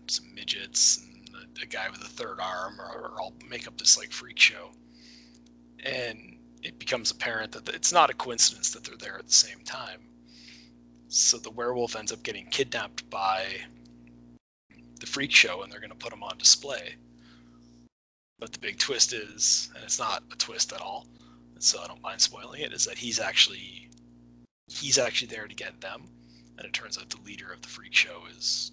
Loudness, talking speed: -25 LUFS, 200 wpm